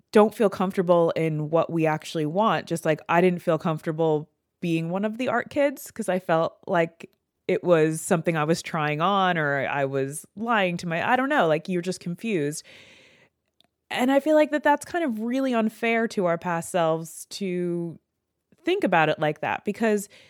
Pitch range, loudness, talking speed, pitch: 165-220 Hz, -24 LUFS, 190 wpm, 180 Hz